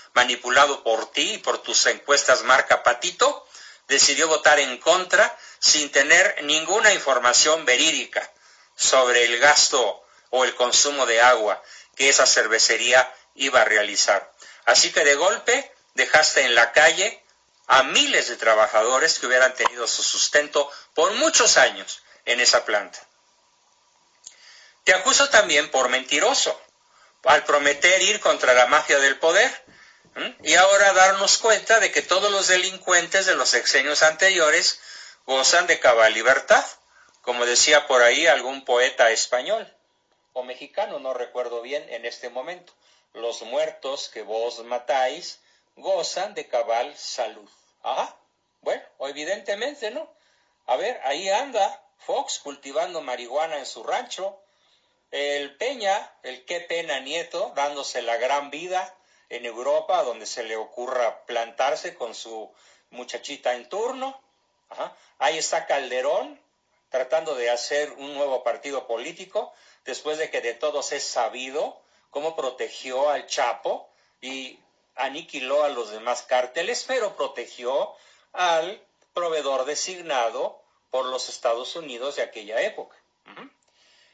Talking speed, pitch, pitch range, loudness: 135 wpm, 145 Hz, 125-185 Hz, -20 LUFS